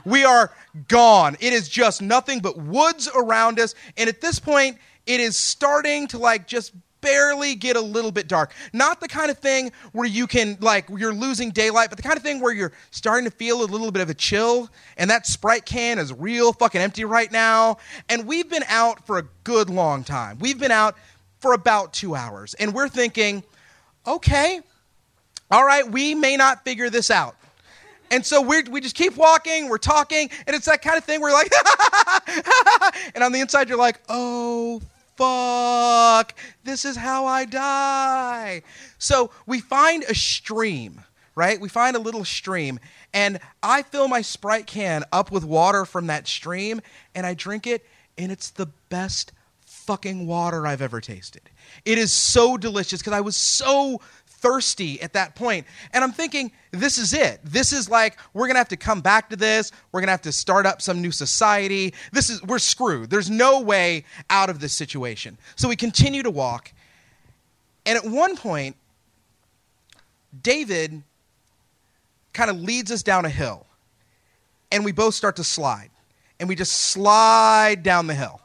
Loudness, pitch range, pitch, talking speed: -20 LUFS, 185-255 Hz, 225 Hz, 185 wpm